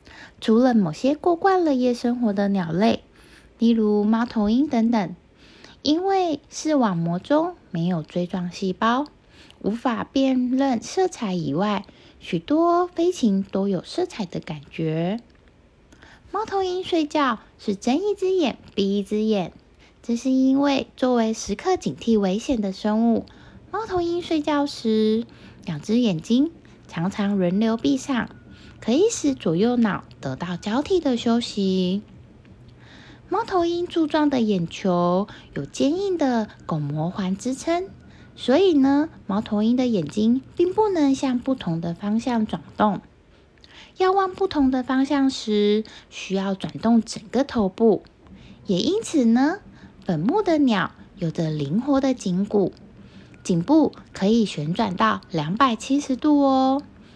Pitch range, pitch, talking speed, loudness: 200-285 Hz, 230 Hz, 200 characters per minute, -22 LUFS